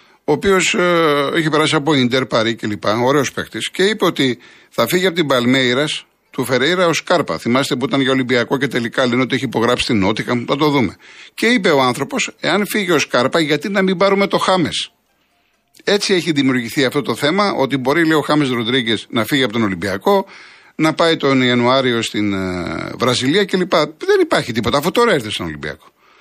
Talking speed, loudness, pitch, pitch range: 195 wpm, -16 LUFS, 135 Hz, 120-170 Hz